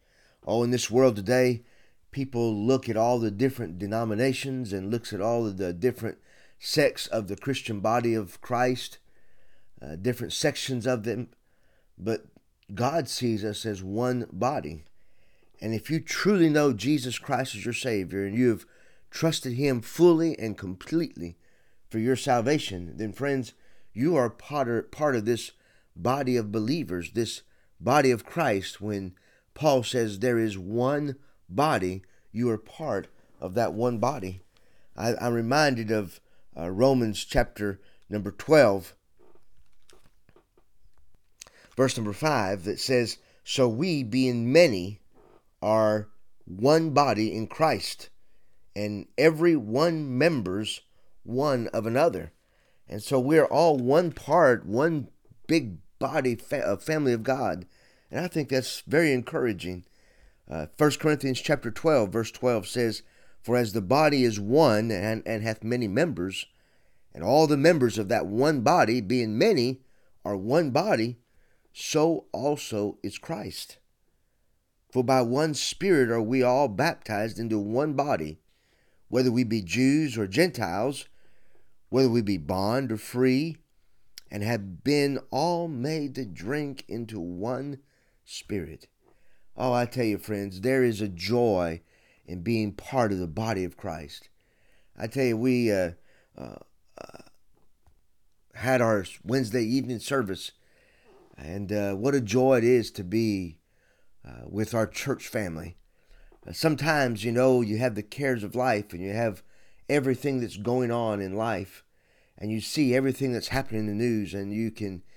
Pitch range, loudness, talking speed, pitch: 105-130 Hz, -26 LUFS, 145 wpm, 120 Hz